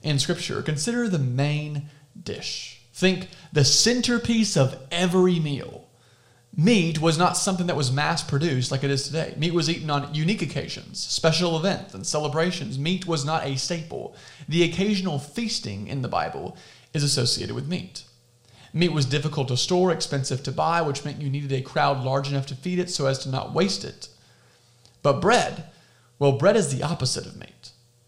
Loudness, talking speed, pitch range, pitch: -24 LUFS, 175 wpm, 135-175 Hz, 150 Hz